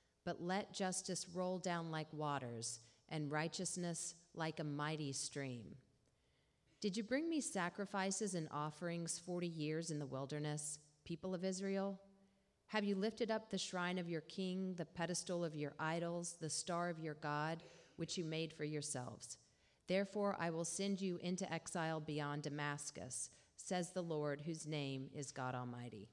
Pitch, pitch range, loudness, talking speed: 170 Hz, 150-185 Hz, -44 LUFS, 160 wpm